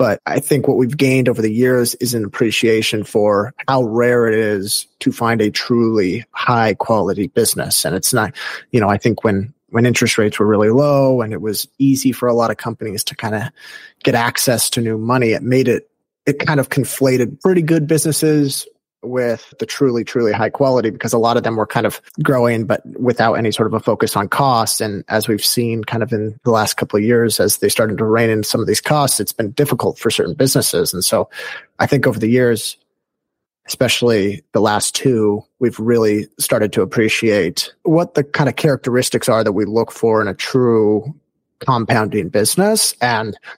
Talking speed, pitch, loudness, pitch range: 205 wpm, 115 Hz, -16 LUFS, 110-130 Hz